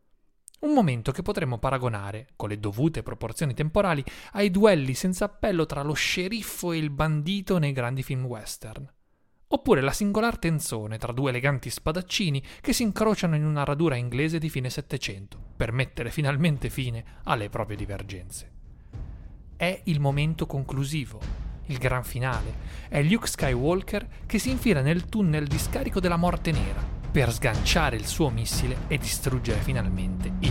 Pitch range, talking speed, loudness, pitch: 120-170 Hz, 155 wpm, -27 LUFS, 140 Hz